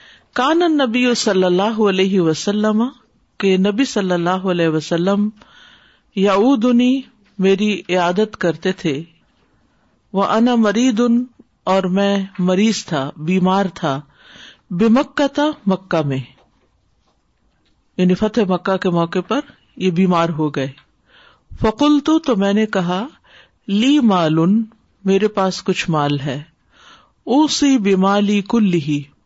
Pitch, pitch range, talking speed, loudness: 195 Hz, 175-230 Hz, 115 wpm, -17 LUFS